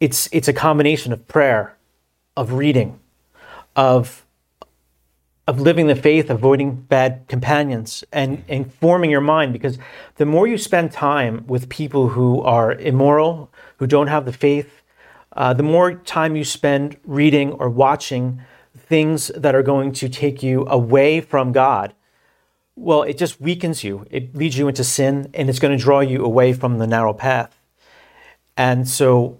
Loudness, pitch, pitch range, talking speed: -17 LUFS, 135 Hz, 125-150 Hz, 160 wpm